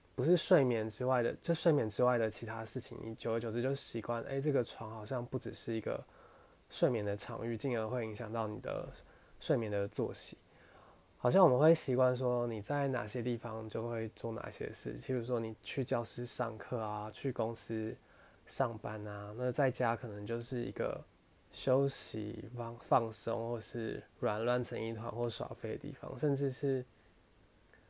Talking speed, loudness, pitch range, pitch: 260 characters per minute, -36 LUFS, 110-130 Hz, 120 Hz